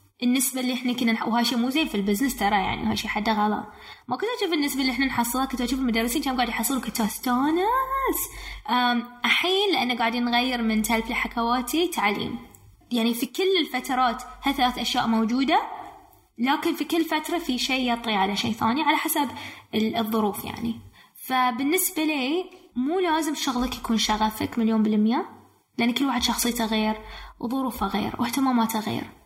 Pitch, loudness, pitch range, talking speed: 250 Hz, -24 LUFS, 230-290 Hz, 160 wpm